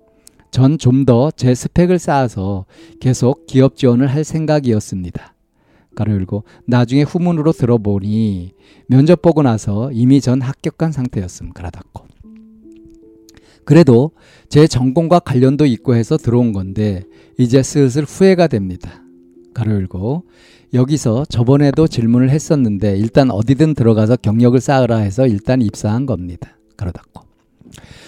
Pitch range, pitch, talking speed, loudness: 105-140 Hz, 125 Hz, 290 characters per minute, -14 LUFS